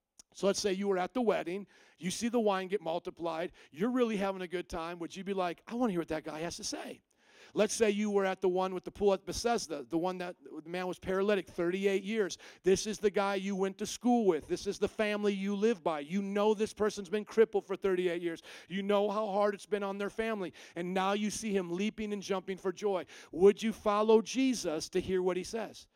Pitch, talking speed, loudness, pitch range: 195 Hz, 250 wpm, -33 LUFS, 180-210 Hz